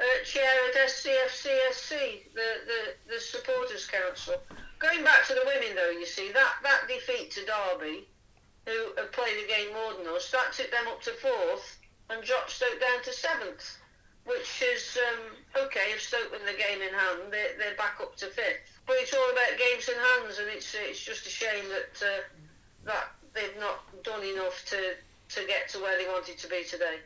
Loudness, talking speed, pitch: -29 LUFS, 195 wpm, 245 Hz